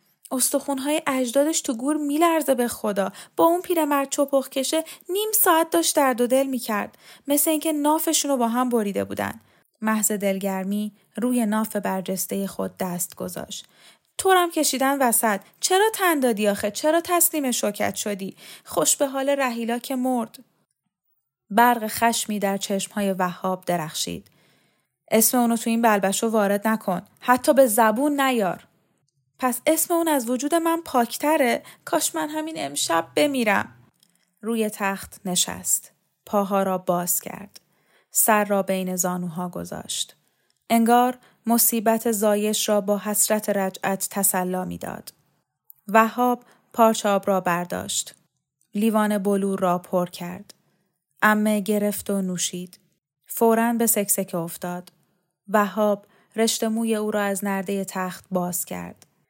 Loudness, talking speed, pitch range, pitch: -22 LUFS, 130 wpm, 190-260 Hz, 215 Hz